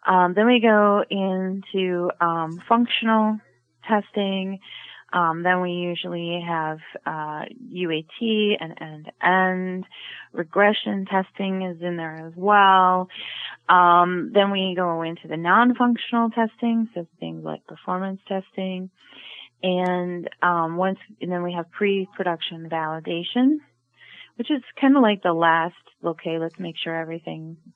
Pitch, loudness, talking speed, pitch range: 185 Hz, -22 LUFS, 125 wpm, 170-205 Hz